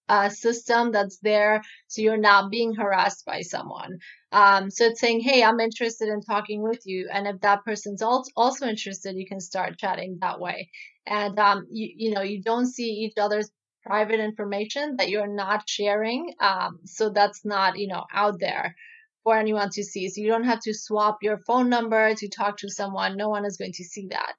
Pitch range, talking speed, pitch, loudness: 200-225 Hz, 205 wpm, 210 Hz, -24 LUFS